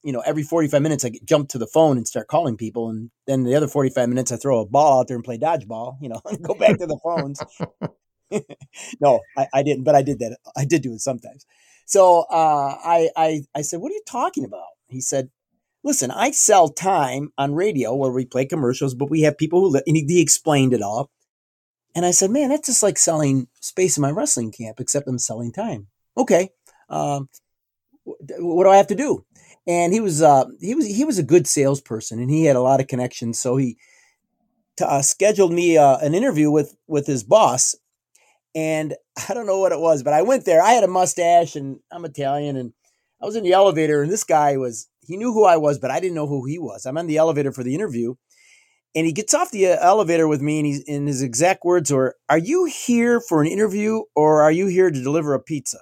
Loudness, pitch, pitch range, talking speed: -19 LUFS, 150 Hz, 135-180 Hz, 235 wpm